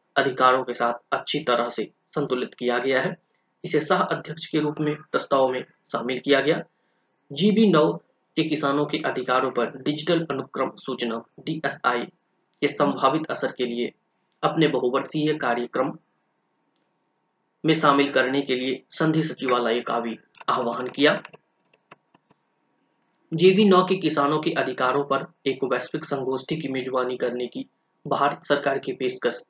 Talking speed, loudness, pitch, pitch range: 140 wpm, -24 LUFS, 140 Hz, 130-160 Hz